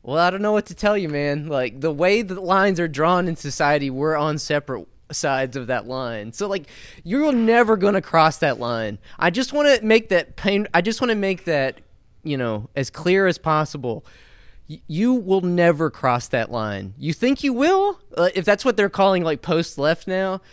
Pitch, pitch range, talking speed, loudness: 165 Hz, 135-195 Hz, 215 wpm, -21 LUFS